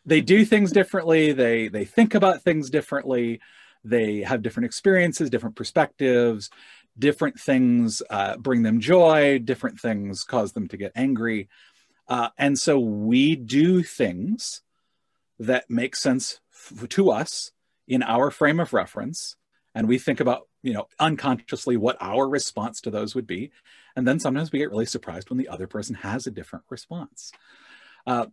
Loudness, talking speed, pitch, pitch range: -23 LUFS, 160 wpm, 135 Hz, 115-165 Hz